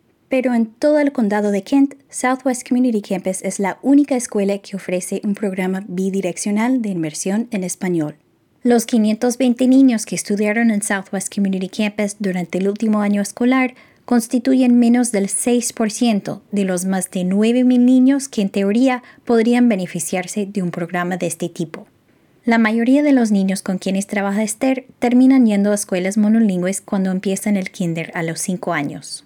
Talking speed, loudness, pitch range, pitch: 165 wpm, -18 LUFS, 190-245 Hz, 210 Hz